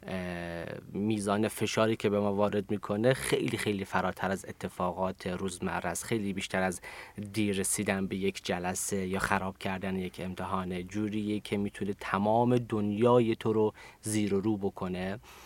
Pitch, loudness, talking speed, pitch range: 100 Hz, -31 LUFS, 145 wpm, 95-105 Hz